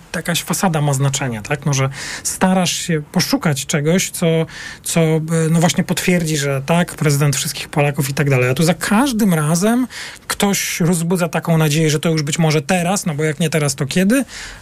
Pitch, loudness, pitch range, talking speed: 165 Hz, -17 LUFS, 150-180 Hz, 190 wpm